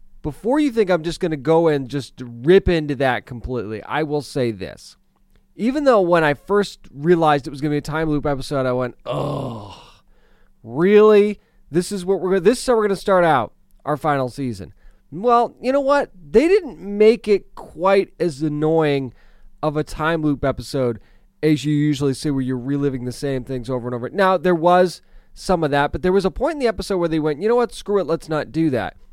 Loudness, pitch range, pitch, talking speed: -19 LUFS, 140-195 Hz, 155 Hz, 220 wpm